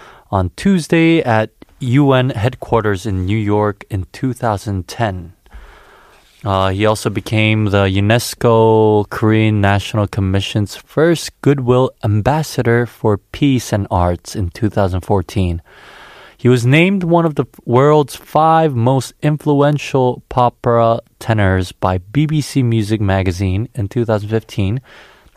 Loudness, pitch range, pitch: -15 LUFS, 100-130 Hz, 110 Hz